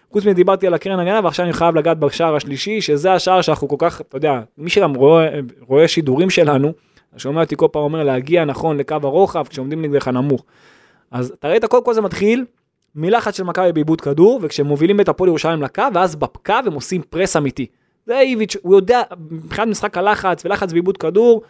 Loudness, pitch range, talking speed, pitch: -16 LUFS, 145-195 Hz, 195 wpm, 165 Hz